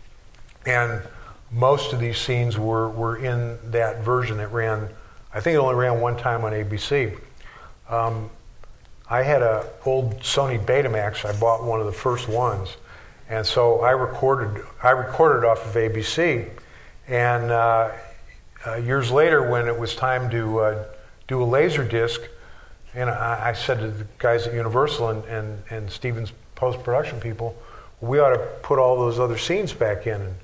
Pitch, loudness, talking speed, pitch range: 115 Hz, -22 LUFS, 170 wpm, 110-125 Hz